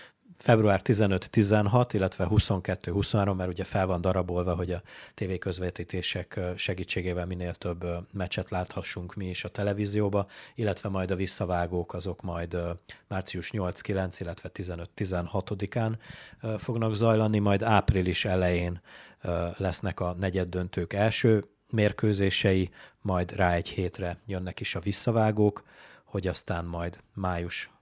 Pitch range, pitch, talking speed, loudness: 90-105 Hz, 95 Hz, 120 wpm, -28 LUFS